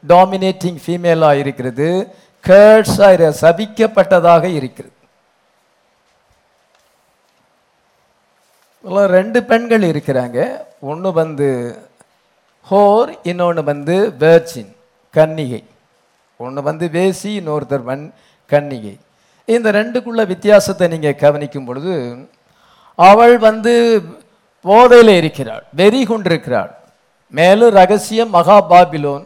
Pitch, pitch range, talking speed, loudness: 175 Hz, 145-205 Hz, 75 wpm, -12 LUFS